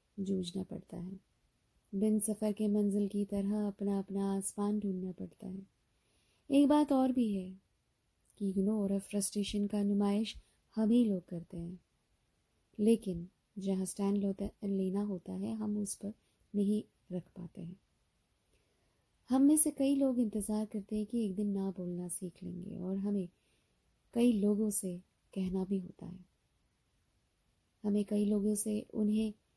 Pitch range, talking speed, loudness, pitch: 190-215 Hz, 145 wpm, -34 LUFS, 205 Hz